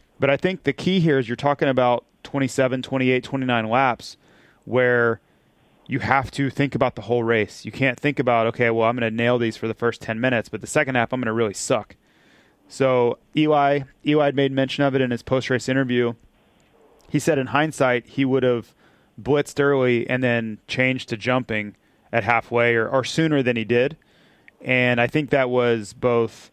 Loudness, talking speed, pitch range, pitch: -21 LUFS, 200 wpm, 115-135 Hz, 125 Hz